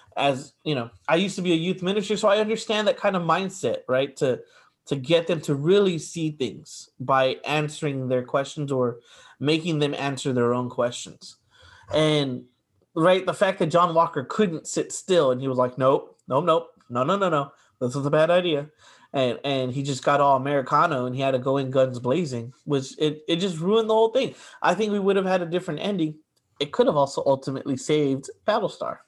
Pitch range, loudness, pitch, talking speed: 130-175 Hz, -24 LUFS, 145 Hz, 210 wpm